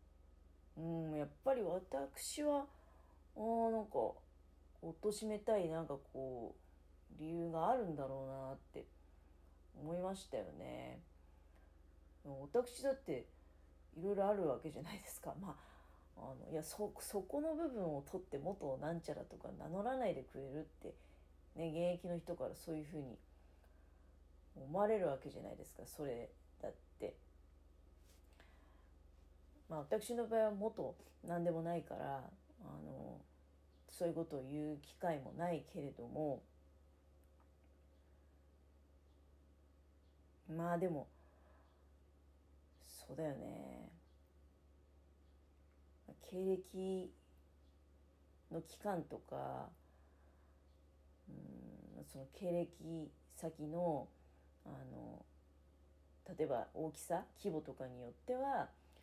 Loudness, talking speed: -44 LUFS, 190 characters per minute